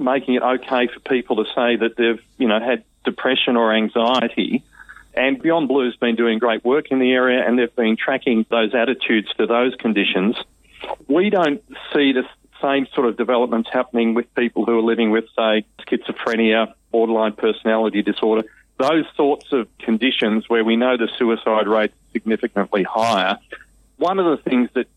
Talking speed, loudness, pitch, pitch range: 175 wpm, -19 LUFS, 115 Hz, 110-125 Hz